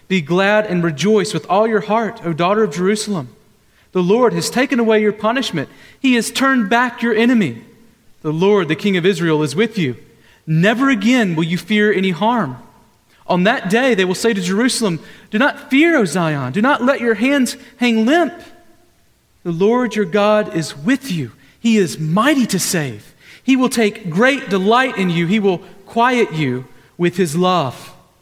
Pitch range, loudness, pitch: 175-235 Hz, -16 LUFS, 210 Hz